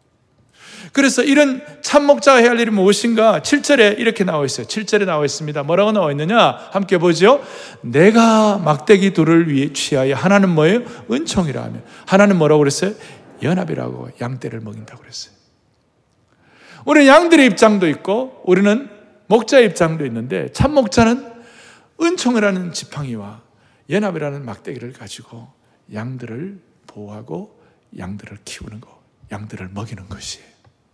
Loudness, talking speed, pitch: -15 LUFS, 330 characters per minute, 175 Hz